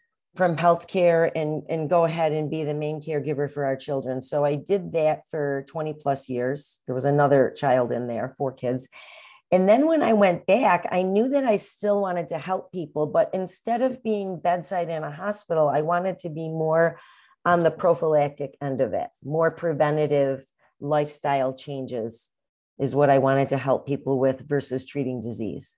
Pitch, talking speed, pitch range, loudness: 155 Hz, 185 wpm, 140-175 Hz, -24 LUFS